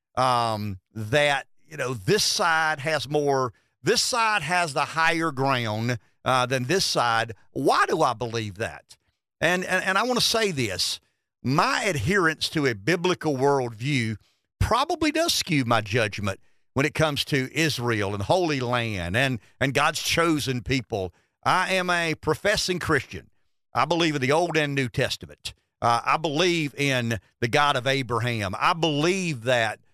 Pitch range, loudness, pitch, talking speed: 115-160 Hz, -24 LUFS, 135 Hz, 160 wpm